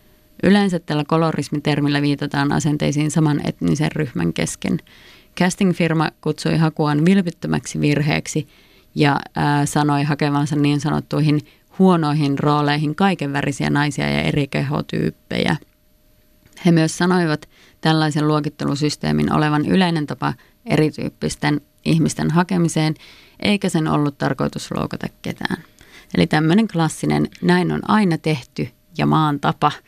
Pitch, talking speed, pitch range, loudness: 150 Hz, 110 wpm, 145-165 Hz, -19 LUFS